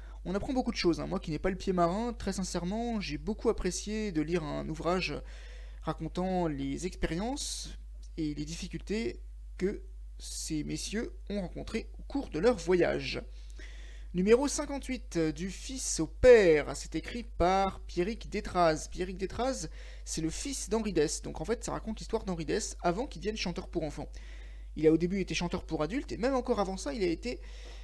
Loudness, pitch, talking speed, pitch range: -32 LUFS, 180 Hz, 185 wpm, 160-220 Hz